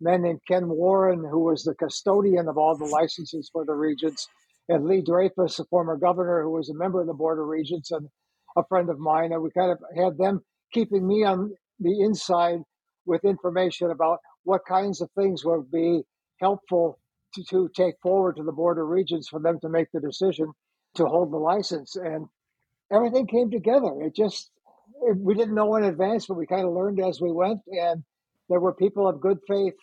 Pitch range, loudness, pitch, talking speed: 165-190 Hz, -25 LUFS, 180 Hz, 205 wpm